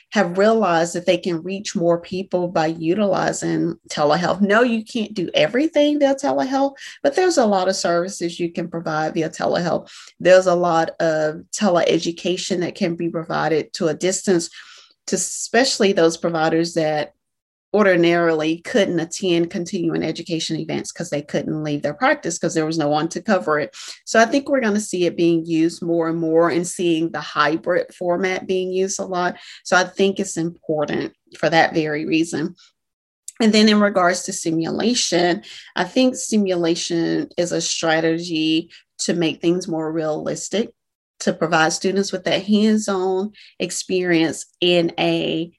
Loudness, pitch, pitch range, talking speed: -20 LUFS, 175 Hz, 165-195 Hz, 165 wpm